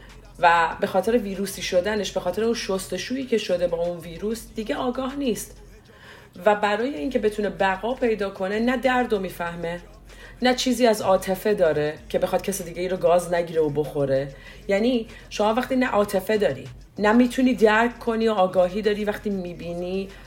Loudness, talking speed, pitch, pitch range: -23 LUFS, 170 wpm, 195 Hz, 175-225 Hz